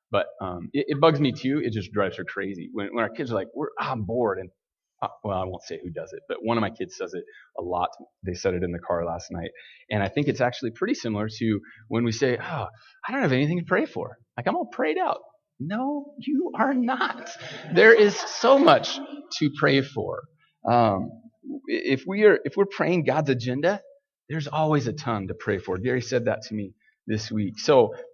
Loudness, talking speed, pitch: -25 LUFS, 230 wpm, 160 Hz